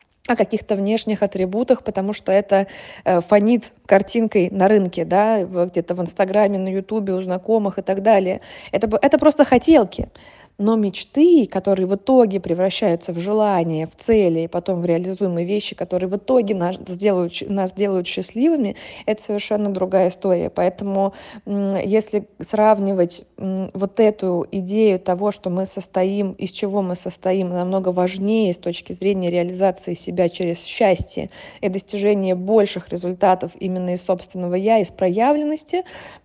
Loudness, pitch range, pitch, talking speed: -19 LUFS, 185-210 Hz, 195 Hz, 145 wpm